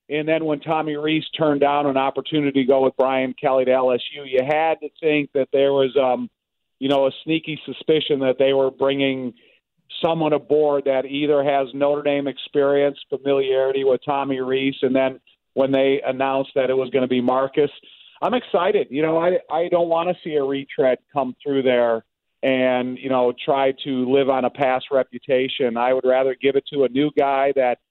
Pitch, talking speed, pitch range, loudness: 135 Hz, 200 wpm, 130-145 Hz, -20 LUFS